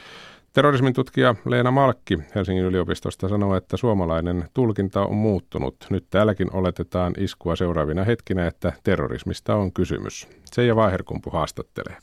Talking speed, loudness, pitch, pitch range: 125 wpm, -23 LUFS, 95 Hz, 90-115 Hz